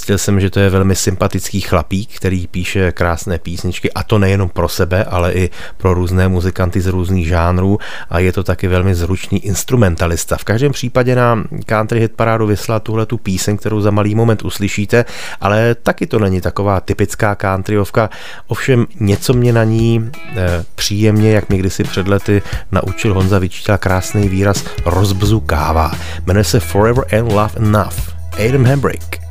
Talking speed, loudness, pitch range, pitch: 170 wpm, -15 LUFS, 90-110 Hz, 100 Hz